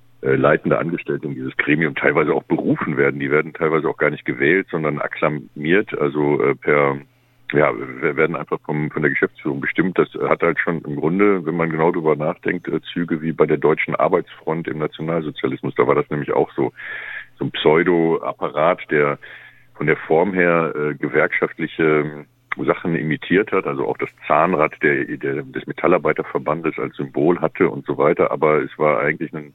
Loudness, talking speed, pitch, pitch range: -19 LUFS, 180 wpm, 75 Hz, 75-85 Hz